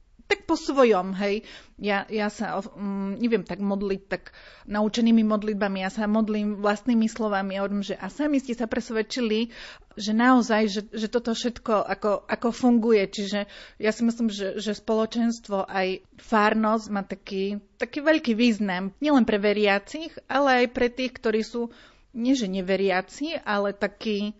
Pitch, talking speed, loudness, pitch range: 215 Hz, 155 wpm, -25 LUFS, 200-235 Hz